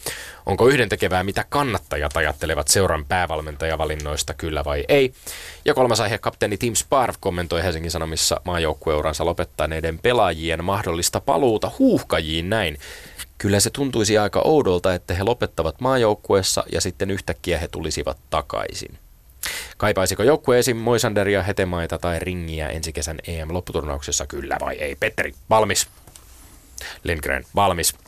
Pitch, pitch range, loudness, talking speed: 90 Hz, 80-105 Hz, -21 LUFS, 125 wpm